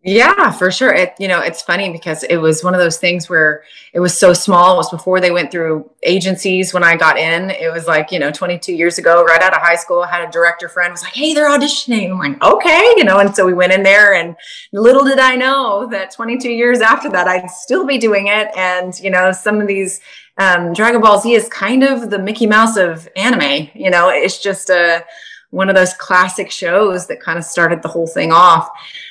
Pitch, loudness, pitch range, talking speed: 185 Hz, -12 LUFS, 175-215 Hz, 240 wpm